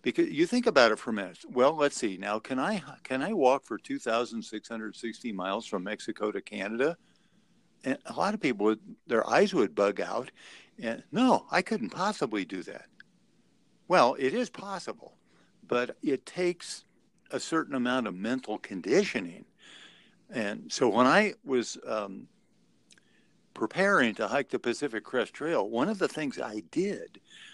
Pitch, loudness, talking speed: 140 Hz, -29 LUFS, 160 wpm